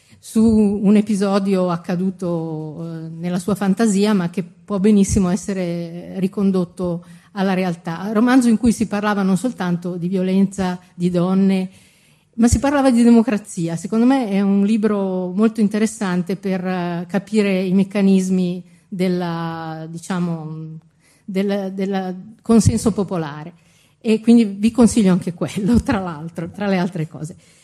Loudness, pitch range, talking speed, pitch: -18 LUFS, 175-210 Hz, 125 wpm, 190 Hz